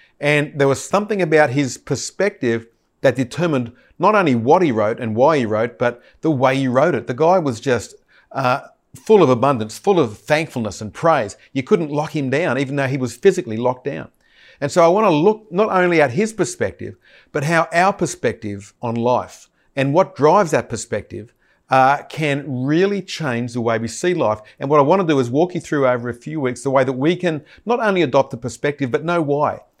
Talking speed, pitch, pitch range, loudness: 215 wpm, 145 Hz, 125-170 Hz, -18 LUFS